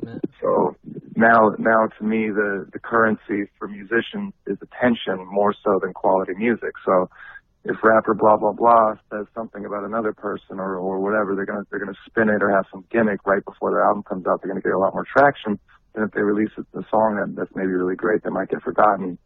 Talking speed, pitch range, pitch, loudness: 220 wpm, 100-110 Hz, 105 Hz, -21 LUFS